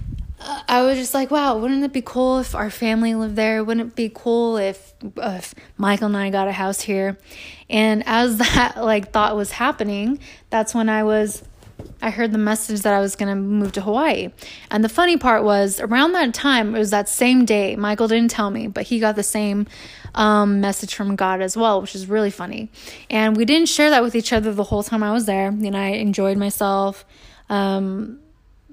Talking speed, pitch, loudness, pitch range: 210 wpm, 215 Hz, -19 LUFS, 205-235 Hz